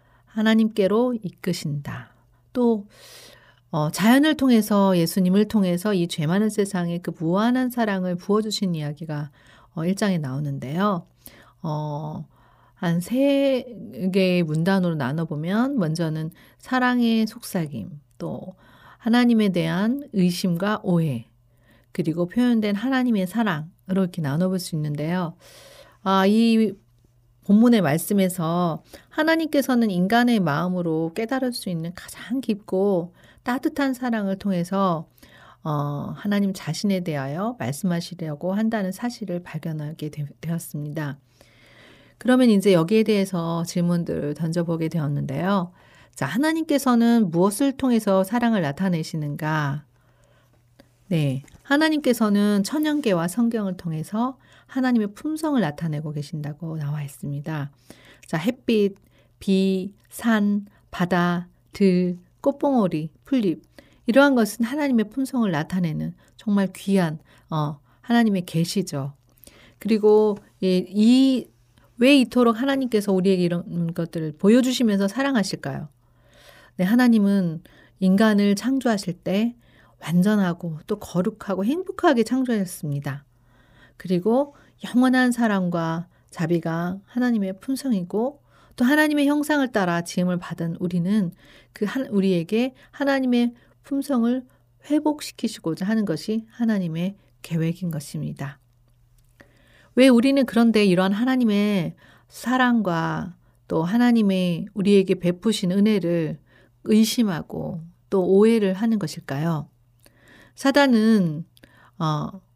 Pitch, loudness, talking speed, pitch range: 190 Hz, -22 LUFS, 265 characters per minute, 160-225 Hz